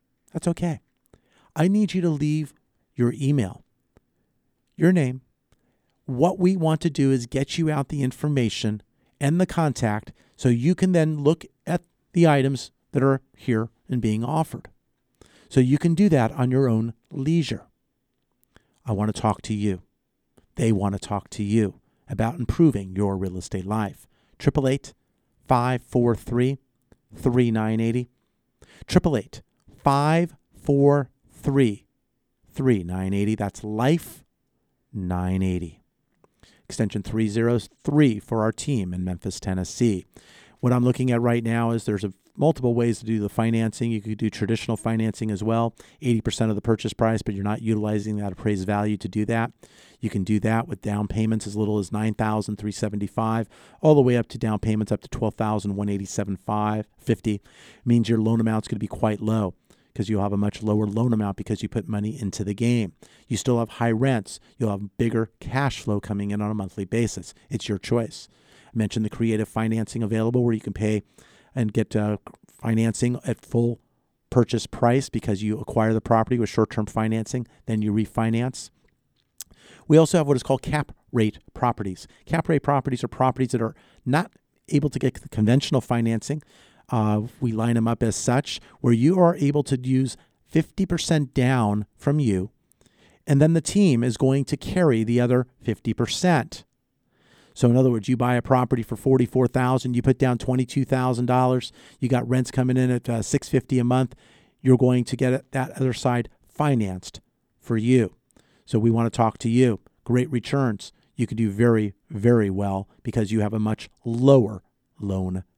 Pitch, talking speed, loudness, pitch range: 115 Hz, 175 wpm, -24 LUFS, 105-130 Hz